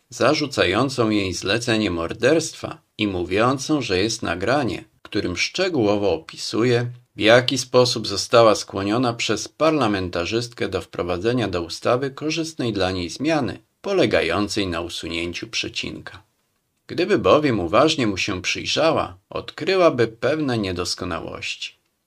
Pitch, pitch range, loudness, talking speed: 115 Hz, 95-125 Hz, -21 LUFS, 110 wpm